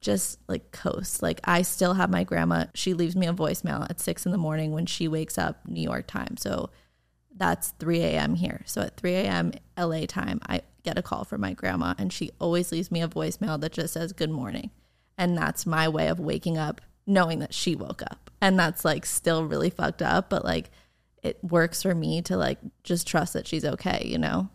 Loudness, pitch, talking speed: -27 LUFS, 160 Hz, 220 wpm